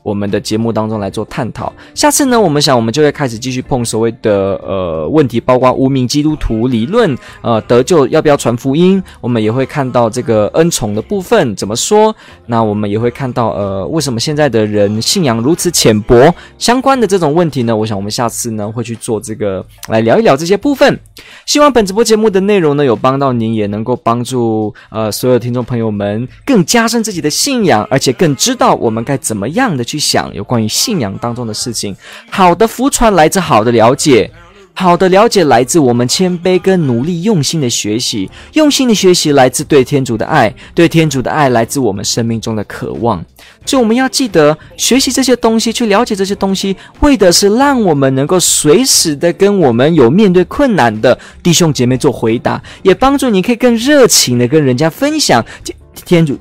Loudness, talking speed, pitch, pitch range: -11 LUFS, 315 characters per minute, 140 Hz, 115-195 Hz